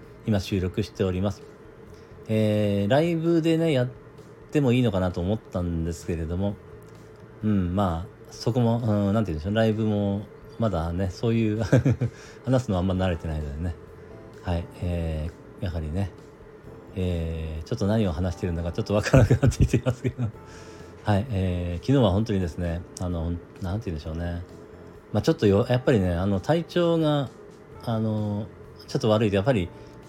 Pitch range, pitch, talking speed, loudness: 90-120 Hz, 105 Hz, 350 characters per minute, -26 LUFS